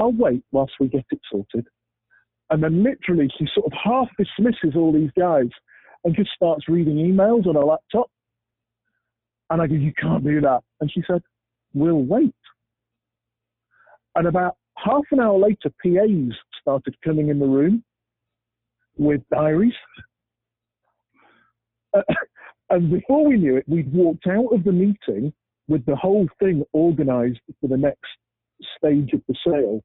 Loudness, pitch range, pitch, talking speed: -20 LUFS, 125-185 Hz, 155 Hz, 150 wpm